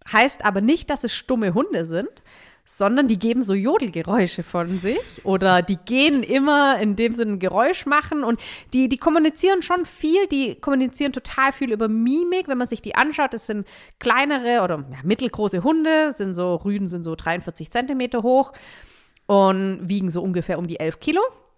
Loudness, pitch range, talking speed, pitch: -21 LUFS, 195-285 Hz, 180 wpm, 235 Hz